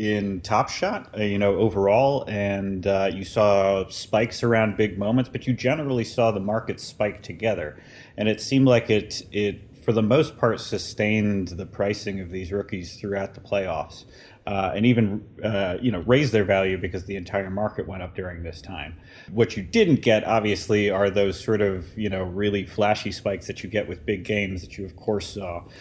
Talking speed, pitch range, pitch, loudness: 195 wpm, 95-110 Hz, 100 Hz, -24 LUFS